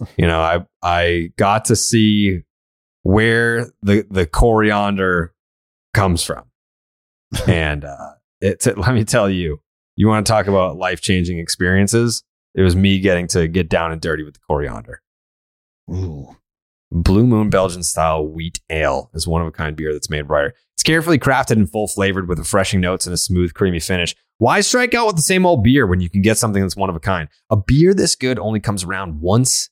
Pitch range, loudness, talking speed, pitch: 85-110 Hz, -17 LUFS, 195 wpm, 95 Hz